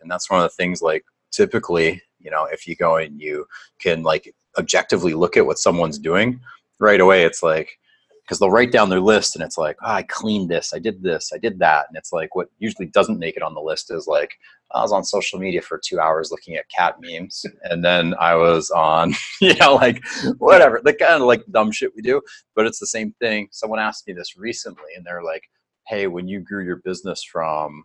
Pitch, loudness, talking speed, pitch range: 90 Hz, -18 LUFS, 235 wpm, 85-130 Hz